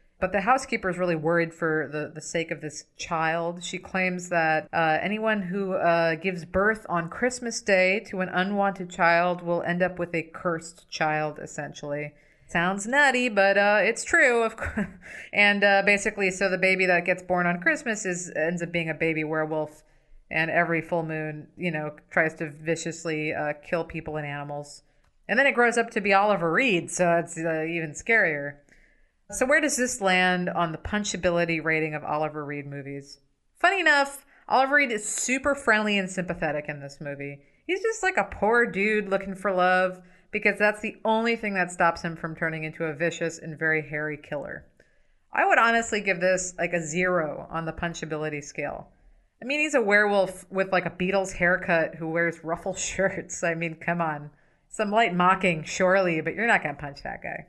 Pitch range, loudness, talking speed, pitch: 160-200 Hz, -25 LUFS, 190 wpm, 175 Hz